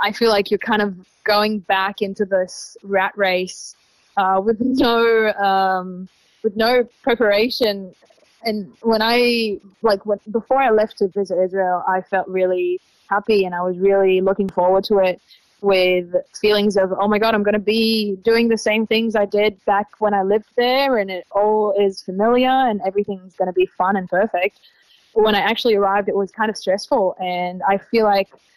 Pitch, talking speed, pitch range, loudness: 205 Hz, 190 wpm, 190-220 Hz, -18 LUFS